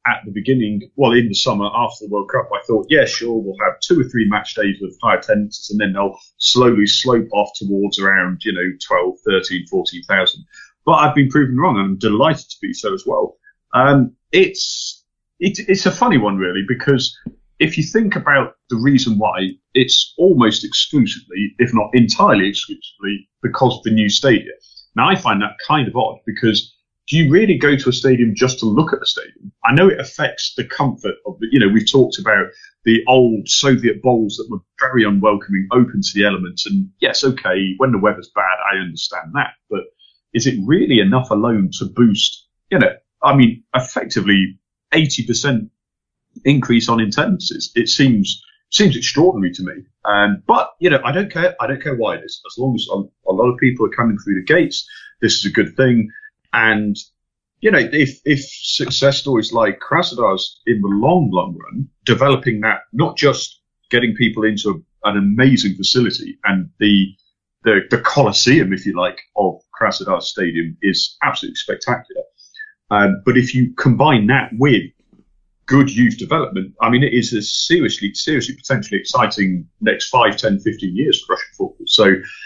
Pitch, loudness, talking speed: 125 Hz, -16 LUFS, 185 wpm